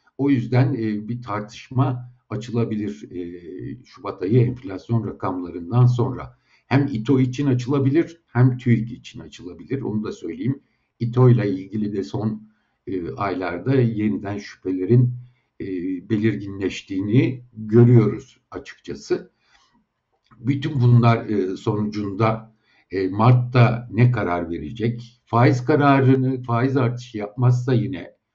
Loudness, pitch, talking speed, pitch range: -21 LUFS, 120 Hz, 95 wpm, 105-125 Hz